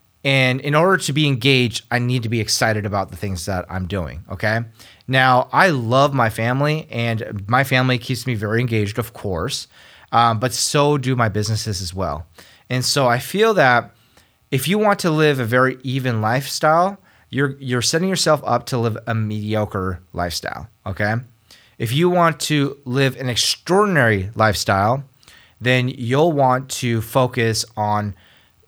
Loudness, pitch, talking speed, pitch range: -19 LUFS, 125 Hz, 165 wpm, 110-135 Hz